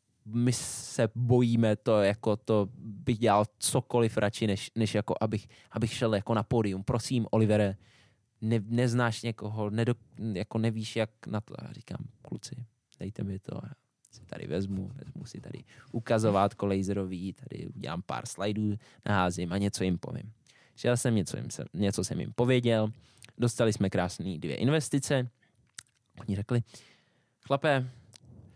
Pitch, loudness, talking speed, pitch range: 115 Hz, -30 LUFS, 145 wpm, 105-120 Hz